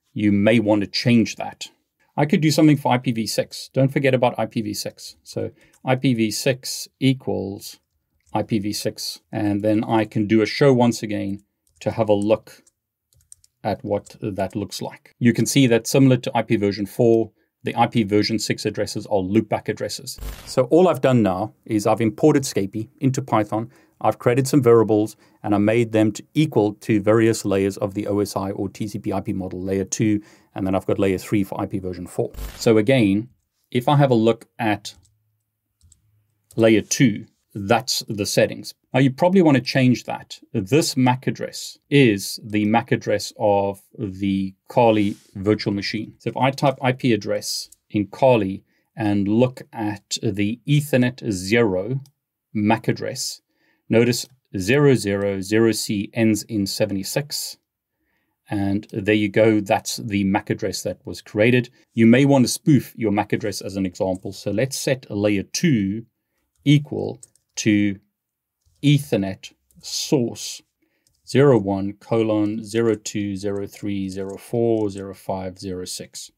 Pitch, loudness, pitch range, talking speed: 110 Hz, -21 LUFS, 100-125 Hz, 145 wpm